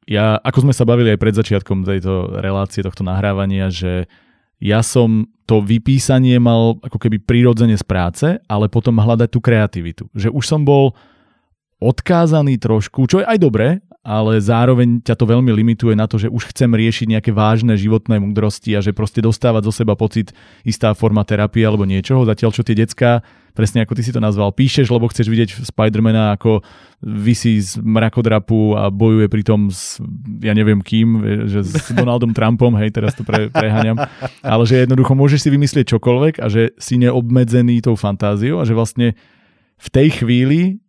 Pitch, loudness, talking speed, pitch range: 115 Hz, -15 LUFS, 175 wpm, 105-120 Hz